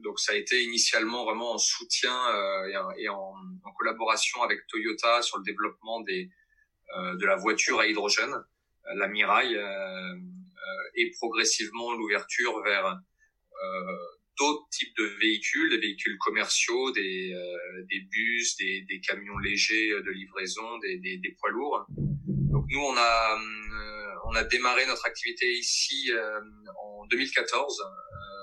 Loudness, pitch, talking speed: -27 LUFS, 115 Hz, 130 wpm